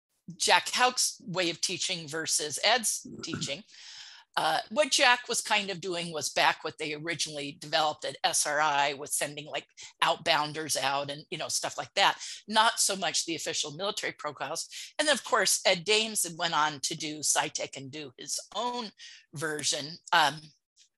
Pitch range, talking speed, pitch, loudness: 150-200 Hz, 165 wpm, 165 Hz, -28 LUFS